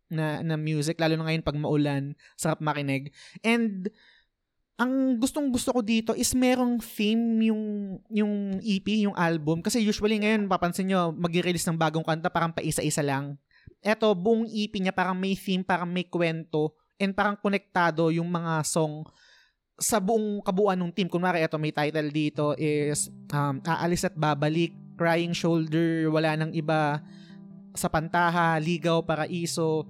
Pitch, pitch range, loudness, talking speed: 175 Hz, 160-205 Hz, -27 LUFS, 155 wpm